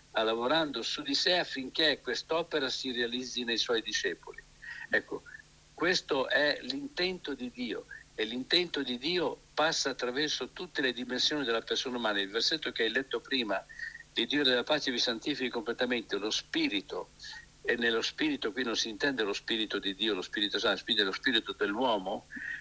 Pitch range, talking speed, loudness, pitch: 125-185 Hz, 160 wpm, -31 LUFS, 140 Hz